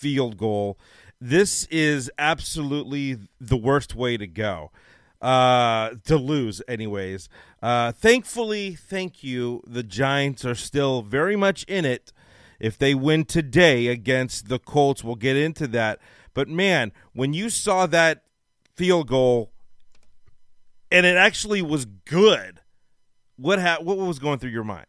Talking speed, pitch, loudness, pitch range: 140 wpm, 135 Hz, -22 LUFS, 115-160 Hz